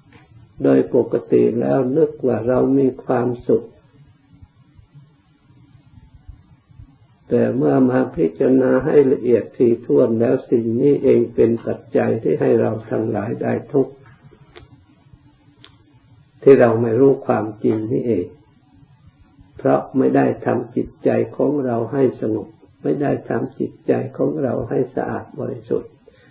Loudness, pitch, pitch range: -18 LUFS, 130 Hz, 115-140 Hz